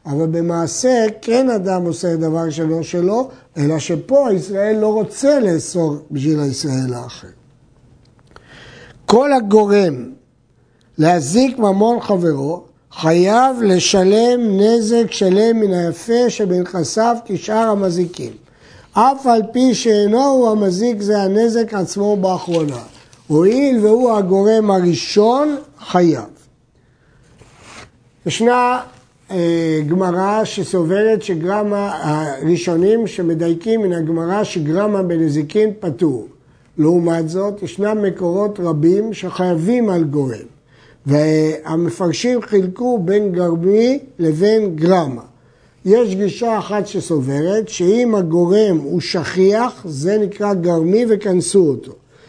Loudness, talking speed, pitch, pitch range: -16 LUFS, 95 wpm, 185 Hz, 160-215 Hz